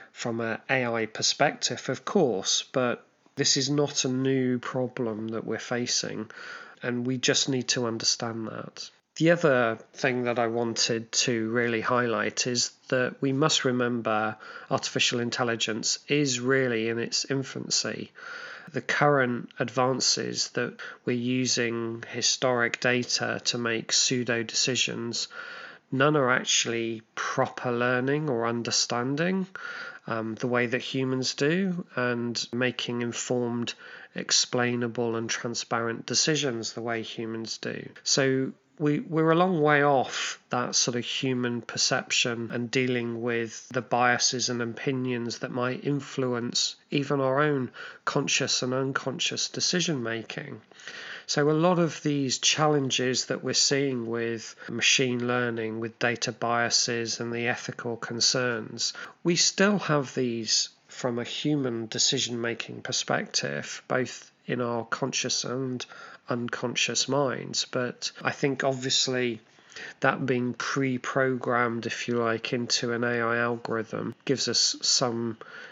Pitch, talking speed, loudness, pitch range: 125 Hz, 130 wpm, -26 LUFS, 115-135 Hz